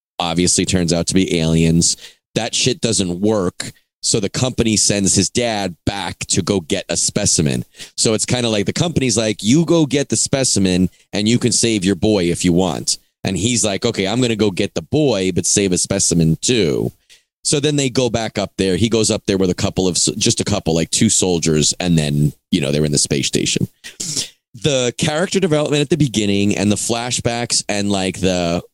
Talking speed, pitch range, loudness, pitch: 215 wpm, 90-120 Hz, -16 LUFS, 100 Hz